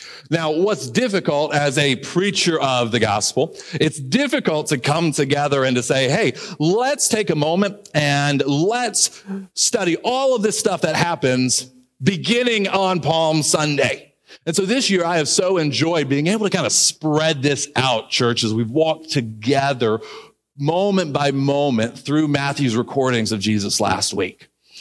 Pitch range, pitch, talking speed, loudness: 135-185 Hz, 150 Hz, 160 wpm, -18 LUFS